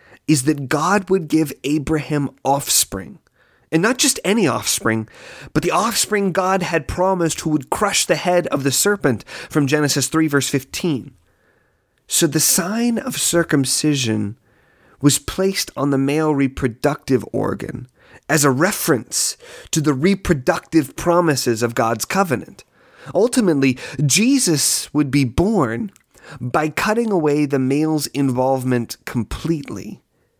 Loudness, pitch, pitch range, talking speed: -18 LUFS, 150 Hz, 135-170 Hz, 130 wpm